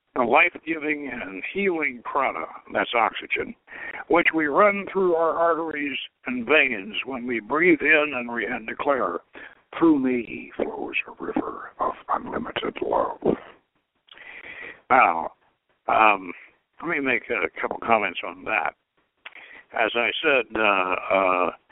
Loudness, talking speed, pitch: -23 LUFS, 130 wpm, 165 Hz